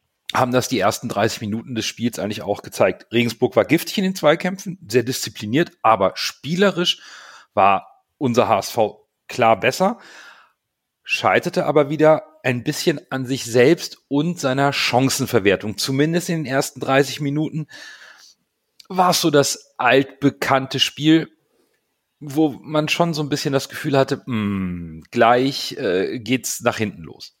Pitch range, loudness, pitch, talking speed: 120-155 Hz, -19 LUFS, 135 Hz, 140 wpm